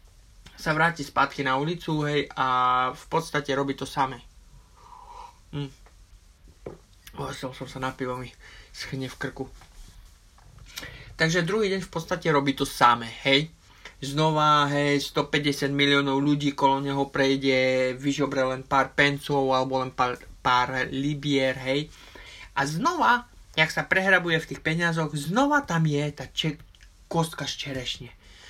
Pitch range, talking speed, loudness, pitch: 130-150 Hz, 140 wpm, -25 LUFS, 140 Hz